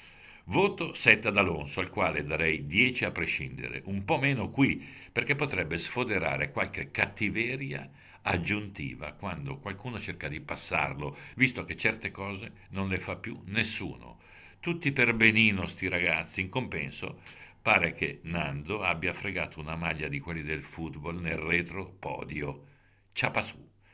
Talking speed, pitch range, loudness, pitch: 145 wpm, 85-115 Hz, -30 LUFS, 100 Hz